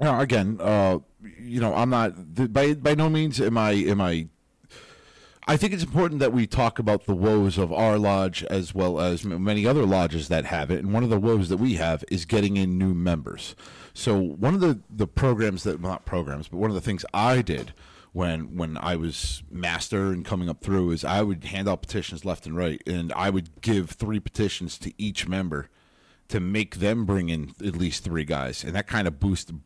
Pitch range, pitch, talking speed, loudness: 85-110 Hz, 95 Hz, 220 wpm, -25 LUFS